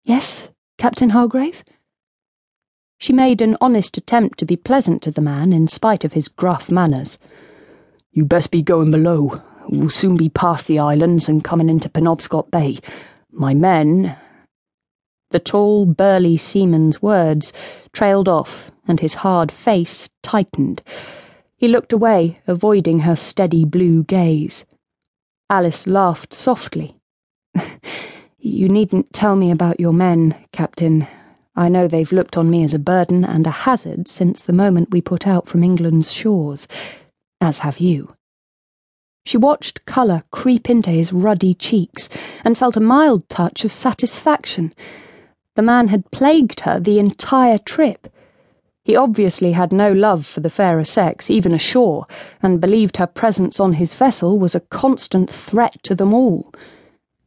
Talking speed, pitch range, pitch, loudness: 150 wpm, 165-215 Hz, 180 Hz, -16 LUFS